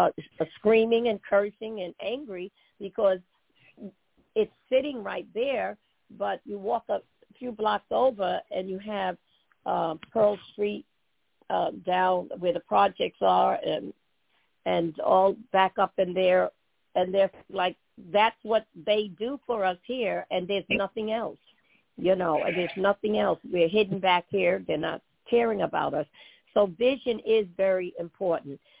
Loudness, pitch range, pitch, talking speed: -27 LUFS, 185-220 Hz, 200 Hz, 150 wpm